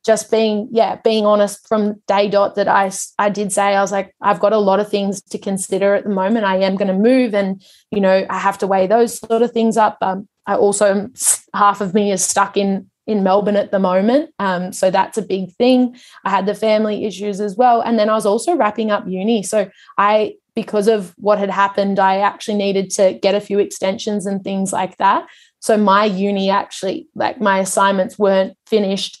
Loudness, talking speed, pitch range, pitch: -16 LUFS, 220 wpm, 195-220 Hz, 205 Hz